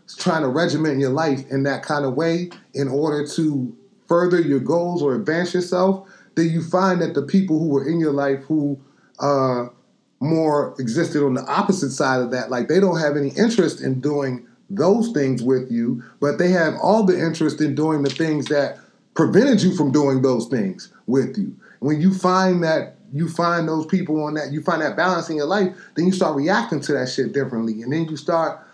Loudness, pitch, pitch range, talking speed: -20 LUFS, 155 Hz, 140-180 Hz, 210 wpm